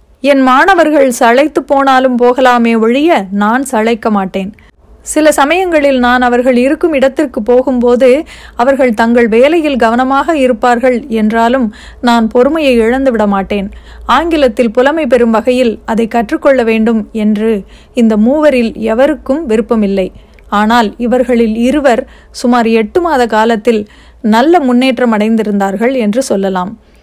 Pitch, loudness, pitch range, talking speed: 245 Hz, -10 LUFS, 225-270 Hz, 110 wpm